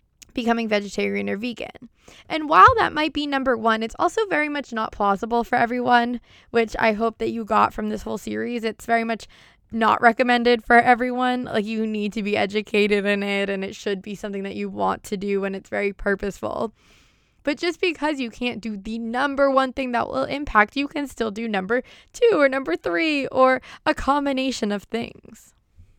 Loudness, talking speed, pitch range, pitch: -22 LUFS, 195 wpm, 210-265 Hz, 230 Hz